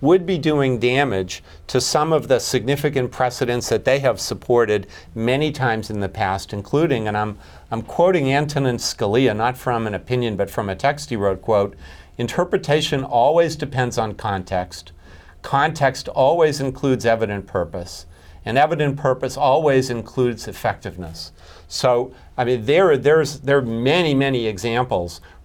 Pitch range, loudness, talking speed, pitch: 95-135 Hz, -20 LUFS, 150 wpm, 120 Hz